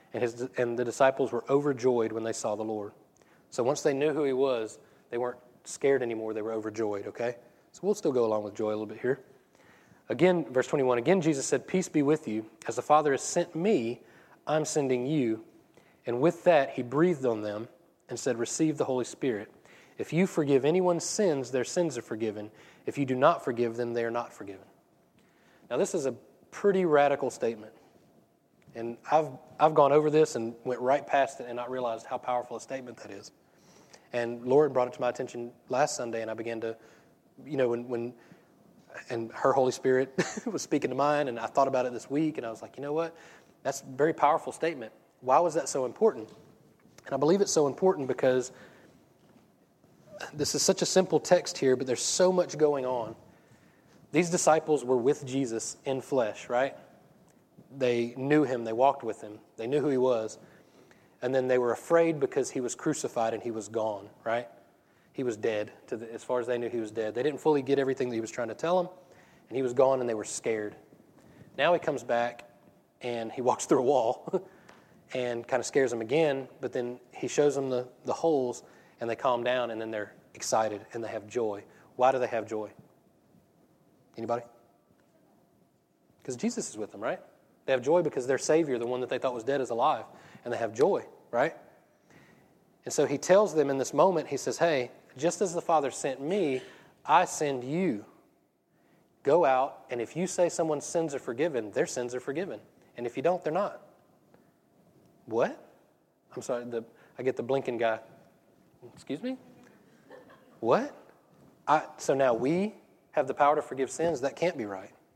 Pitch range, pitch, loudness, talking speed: 120-150 Hz, 130 Hz, -29 LUFS, 200 wpm